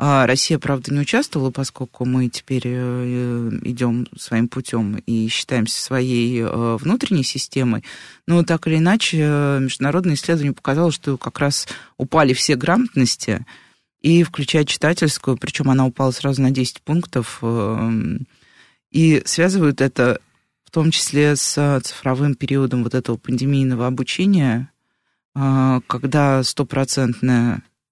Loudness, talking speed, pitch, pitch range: -19 LUFS, 115 wpm, 135 Hz, 125-150 Hz